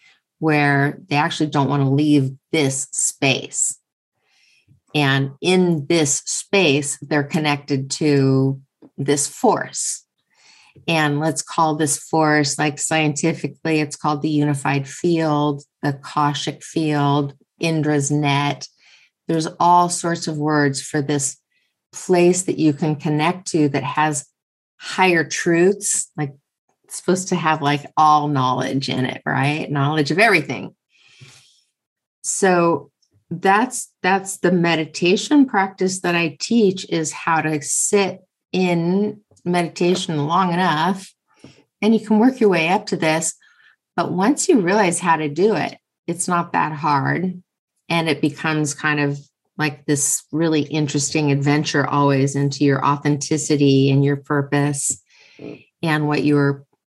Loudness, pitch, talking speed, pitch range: -19 LUFS, 155 Hz, 130 wpm, 145-175 Hz